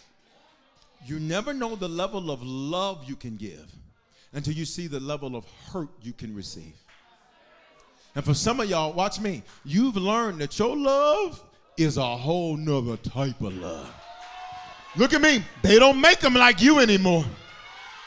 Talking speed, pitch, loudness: 165 wpm, 170 Hz, -22 LUFS